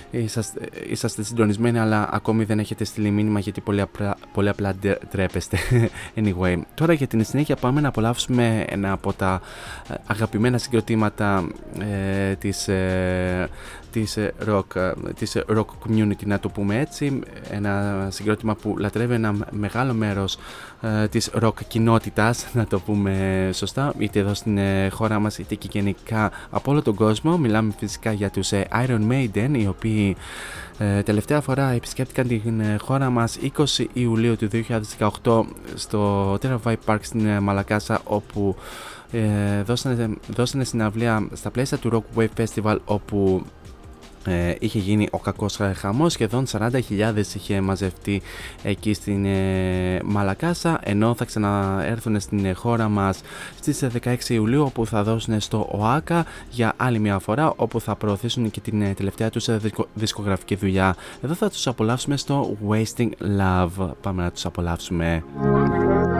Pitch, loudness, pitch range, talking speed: 105 Hz, -23 LUFS, 100-115 Hz, 140 wpm